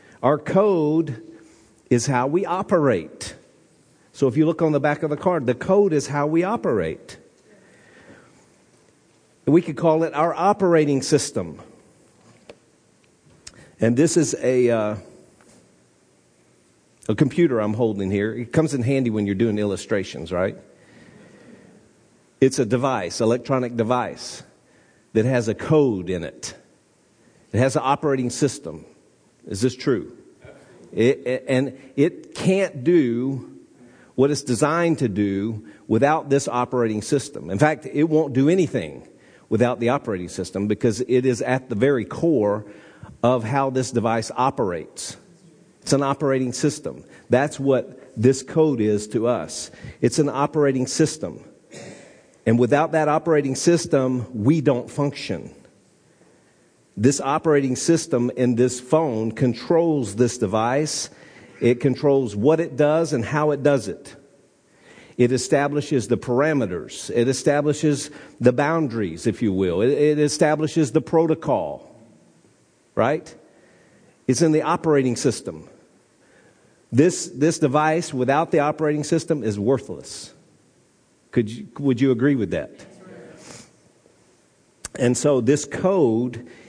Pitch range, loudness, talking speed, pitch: 120-150 Hz, -21 LUFS, 130 wpm, 135 Hz